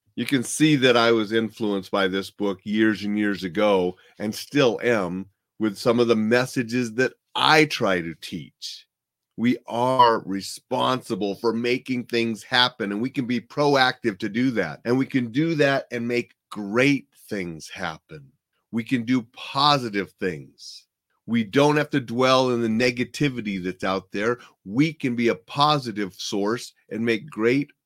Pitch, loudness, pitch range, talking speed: 120 Hz, -23 LUFS, 105-130 Hz, 165 wpm